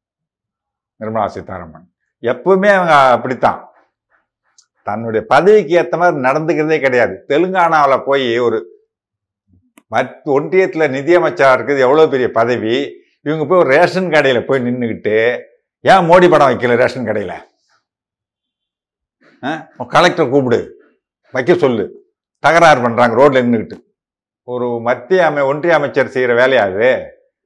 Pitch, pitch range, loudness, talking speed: 150 Hz, 125-190 Hz, -13 LUFS, 110 wpm